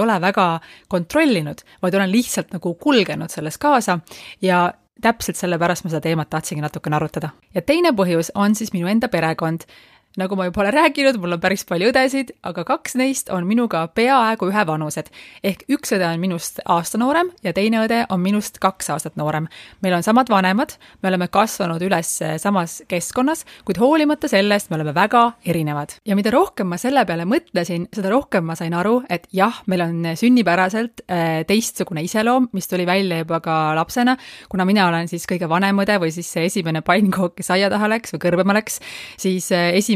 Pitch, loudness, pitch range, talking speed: 190 Hz, -19 LUFS, 170-225 Hz, 185 wpm